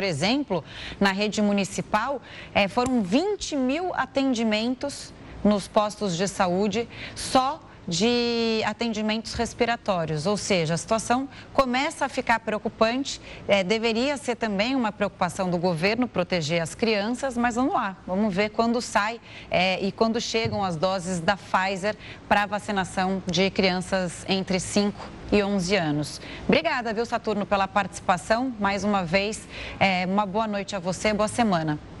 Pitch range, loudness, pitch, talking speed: 195-235 Hz, -25 LUFS, 210 Hz, 145 wpm